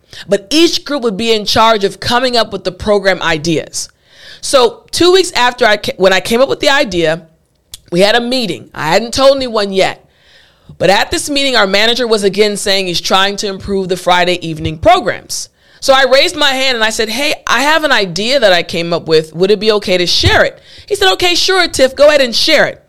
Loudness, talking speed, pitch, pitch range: -11 LUFS, 230 wpm, 225 Hz, 190-280 Hz